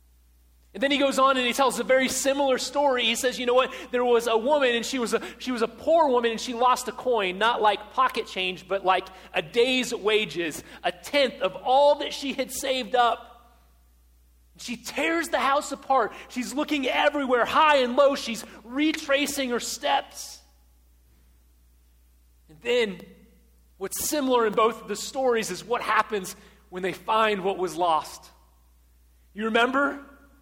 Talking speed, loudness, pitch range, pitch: 175 wpm, -24 LUFS, 185-265 Hz, 235 Hz